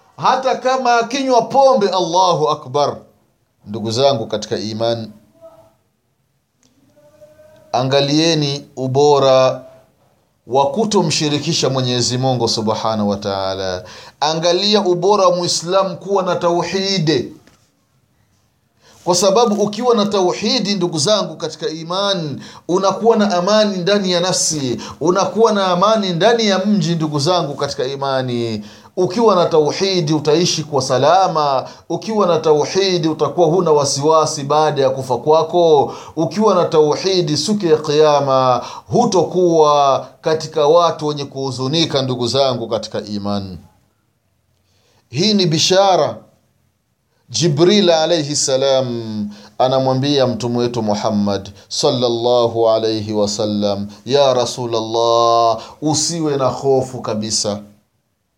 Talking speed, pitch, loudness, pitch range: 100 wpm, 150 Hz, -16 LUFS, 120-180 Hz